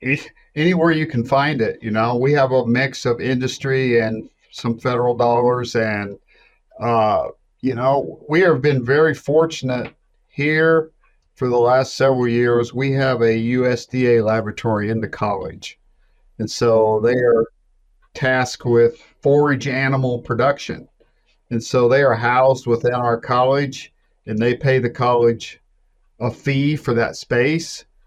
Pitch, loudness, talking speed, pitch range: 125 Hz, -18 LUFS, 145 wpm, 120-135 Hz